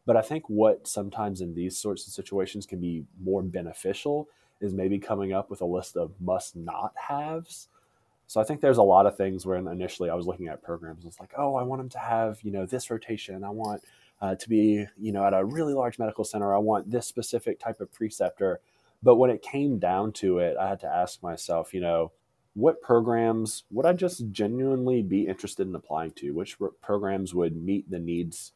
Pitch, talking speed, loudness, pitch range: 105 Hz, 215 wpm, -28 LUFS, 95-120 Hz